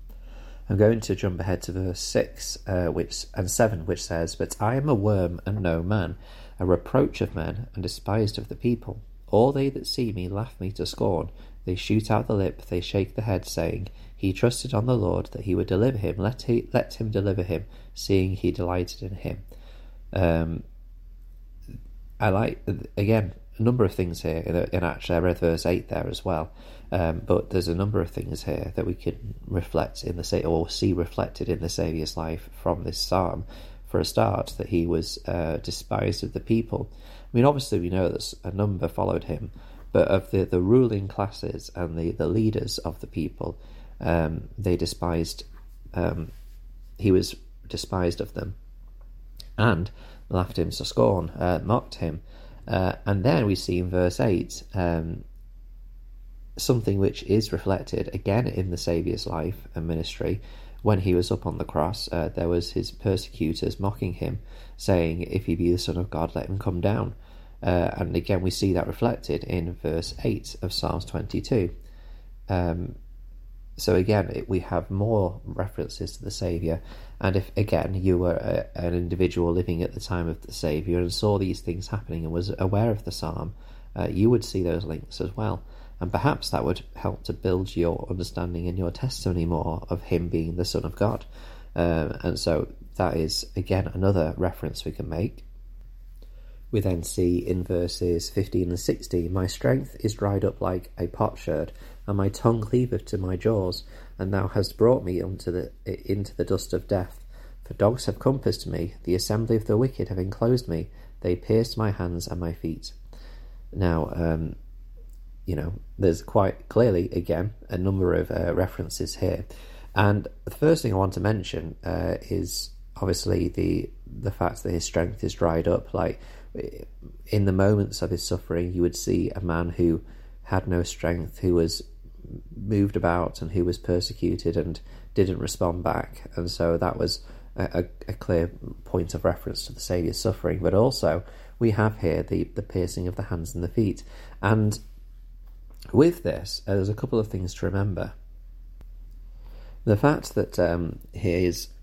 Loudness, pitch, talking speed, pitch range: -26 LUFS, 90 Hz, 185 wpm, 85-105 Hz